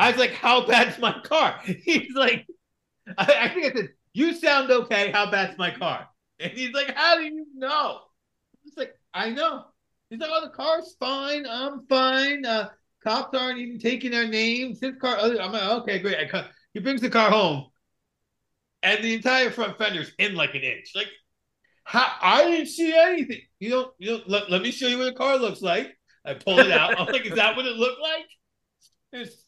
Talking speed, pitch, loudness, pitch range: 210 wpm, 245 Hz, -23 LUFS, 215-275 Hz